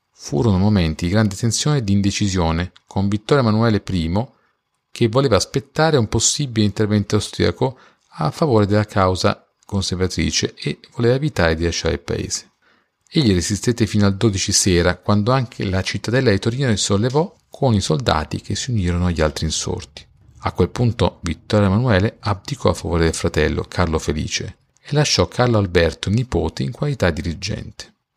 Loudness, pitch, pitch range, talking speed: -19 LUFS, 105 Hz, 90-115 Hz, 160 wpm